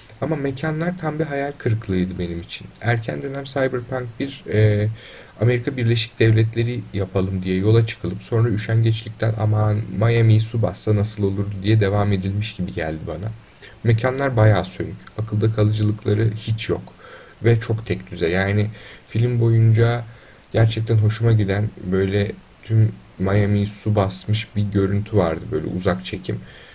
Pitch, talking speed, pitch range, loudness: 110 Hz, 140 wpm, 100-115 Hz, -21 LUFS